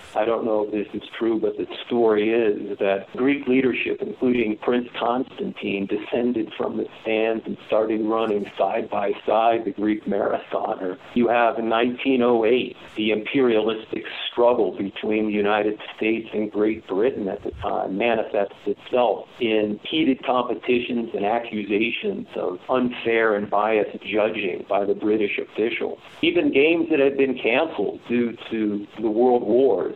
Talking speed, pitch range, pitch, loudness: 150 wpm, 105-125 Hz, 115 Hz, -23 LUFS